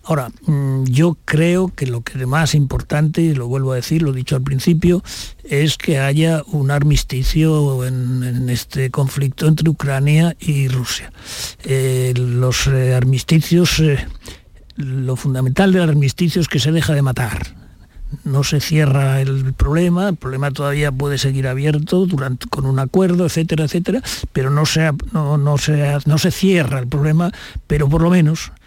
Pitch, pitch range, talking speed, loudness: 145 Hz, 130-160 Hz, 160 wpm, -17 LUFS